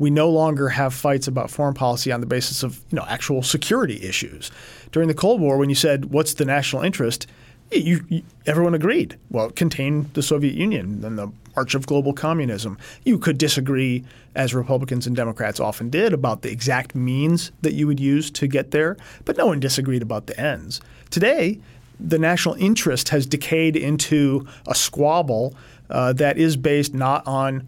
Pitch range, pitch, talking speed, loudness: 125-155 Hz, 140 Hz, 185 wpm, -21 LUFS